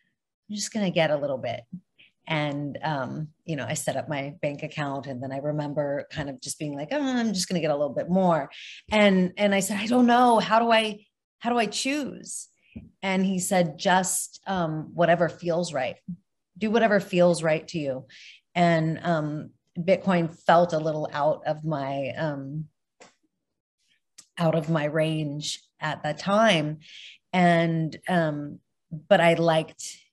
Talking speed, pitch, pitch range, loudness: 165 wpm, 165 Hz, 150-190 Hz, -25 LUFS